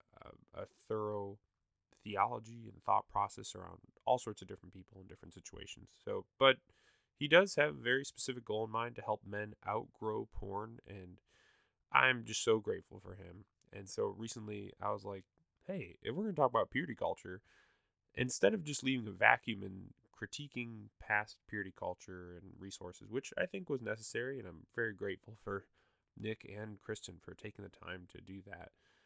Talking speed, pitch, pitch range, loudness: 180 wpm, 105 Hz, 95-115 Hz, -37 LUFS